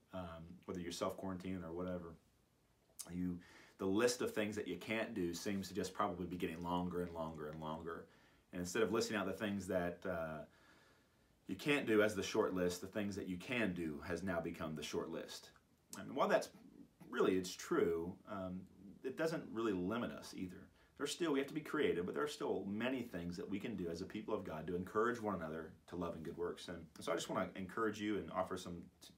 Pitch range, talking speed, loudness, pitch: 85-95 Hz, 230 wpm, -42 LUFS, 90 Hz